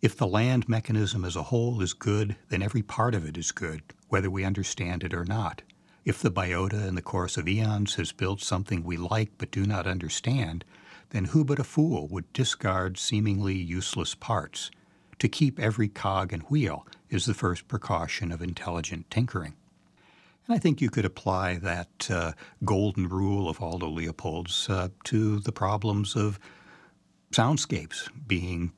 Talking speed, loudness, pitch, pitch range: 170 wpm, -29 LUFS, 95 Hz, 90-110 Hz